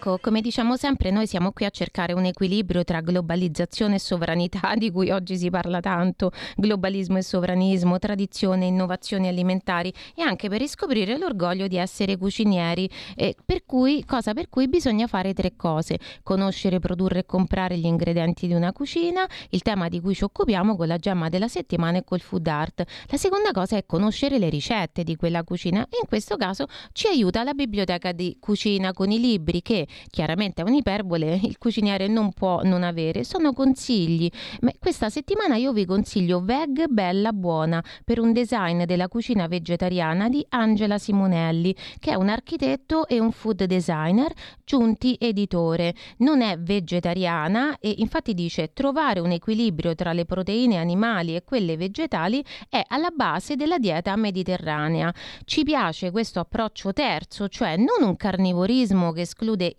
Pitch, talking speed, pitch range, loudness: 195 Hz, 165 wpm, 180-230 Hz, -24 LUFS